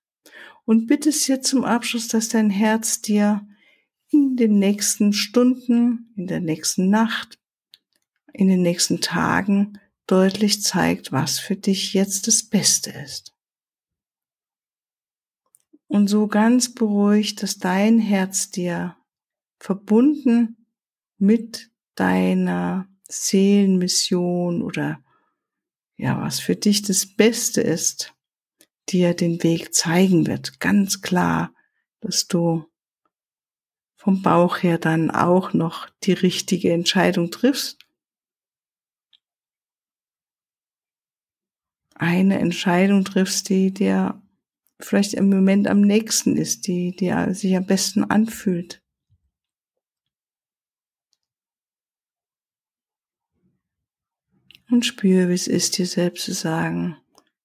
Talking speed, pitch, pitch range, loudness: 100 wpm, 195 Hz, 180-220 Hz, -20 LUFS